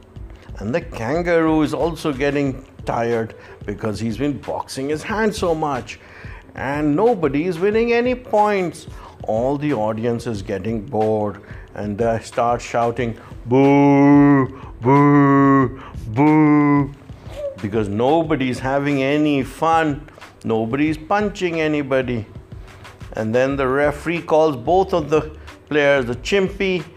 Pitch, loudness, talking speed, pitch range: 135 Hz, -18 LUFS, 120 wpm, 115-155 Hz